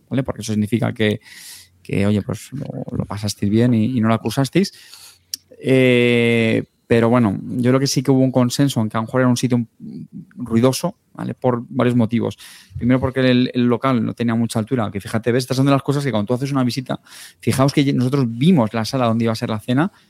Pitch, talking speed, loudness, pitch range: 125 Hz, 225 wpm, -18 LUFS, 115-130 Hz